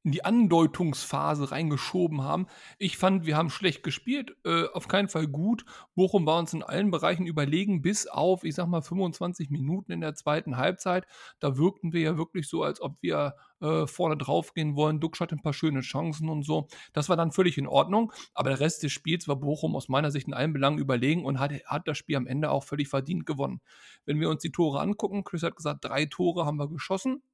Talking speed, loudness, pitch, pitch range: 220 wpm, -28 LUFS, 160 Hz, 145-180 Hz